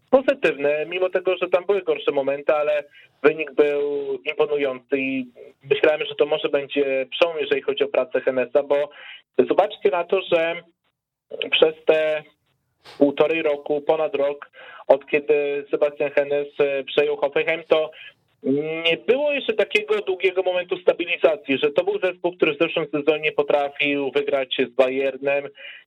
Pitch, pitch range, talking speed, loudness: 150 Hz, 145-190 Hz, 140 wpm, -22 LUFS